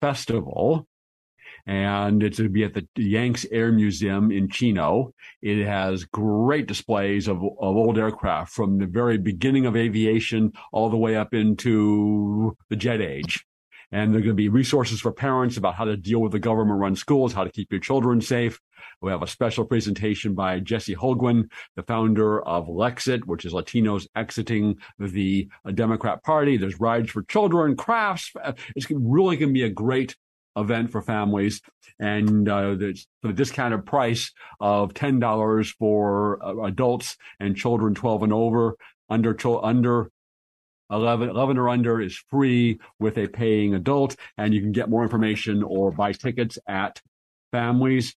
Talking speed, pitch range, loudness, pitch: 160 wpm, 105-120 Hz, -23 LUFS, 110 Hz